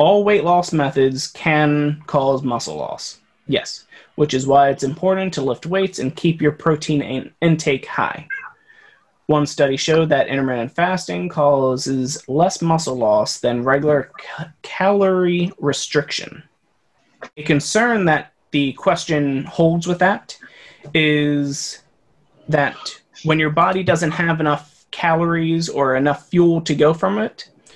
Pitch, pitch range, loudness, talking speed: 155 Hz, 145-175 Hz, -18 LUFS, 135 wpm